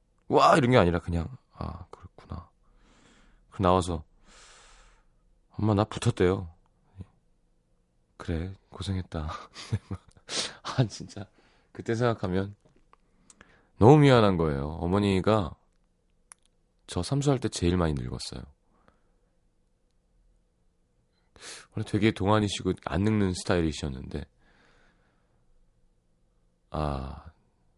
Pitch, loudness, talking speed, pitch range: 90 Hz, -27 LUFS, 180 characters per minute, 75-105 Hz